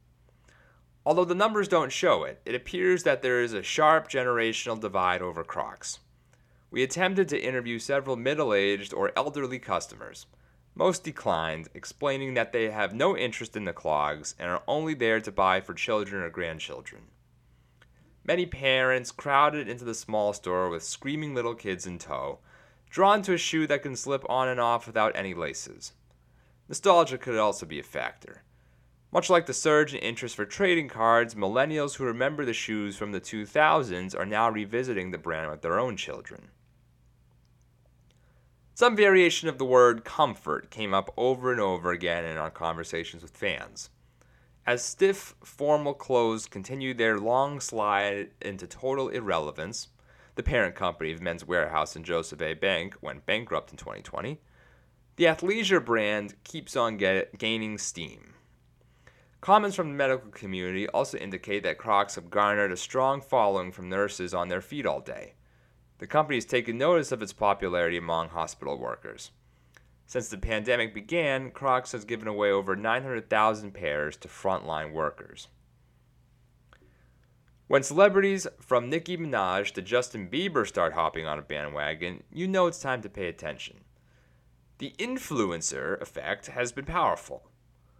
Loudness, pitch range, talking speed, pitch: -28 LUFS, 95-140 Hz, 155 wpm, 120 Hz